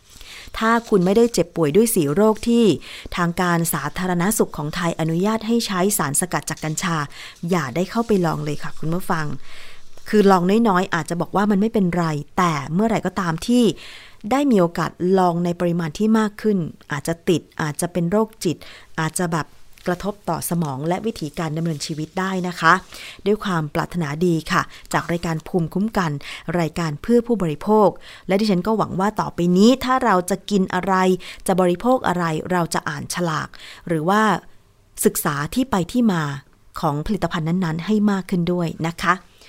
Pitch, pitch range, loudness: 175 Hz, 165-200 Hz, -20 LUFS